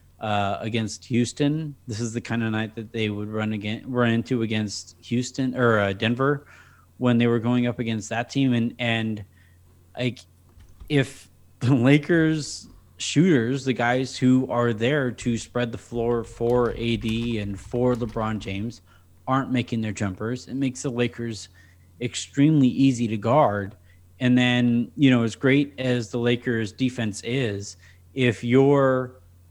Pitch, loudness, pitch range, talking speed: 120 Hz, -24 LUFS, 105-125 Hz, 155 wpm